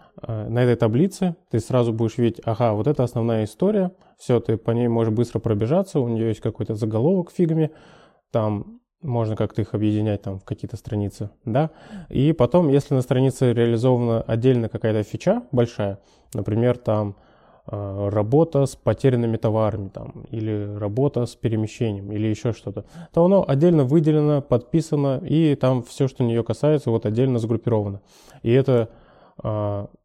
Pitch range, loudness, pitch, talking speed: 110-145 Hz, -22 LUFS, 120 Hz, 150 wpm